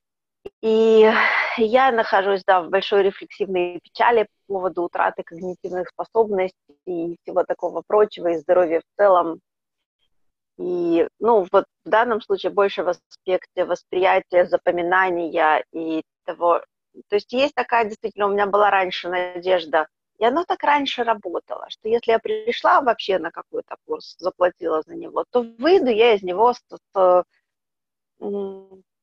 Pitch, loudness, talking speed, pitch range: 195 Hz, -20 LUFS, 135 wpm, 180-230 Hz